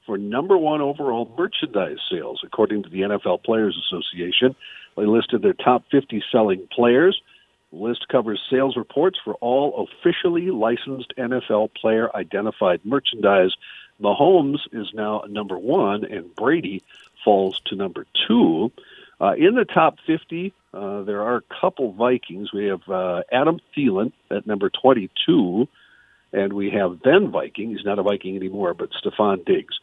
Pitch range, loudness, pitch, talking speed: 100-150 Hz, -21 LUFS, 115 Hz, 150 wpm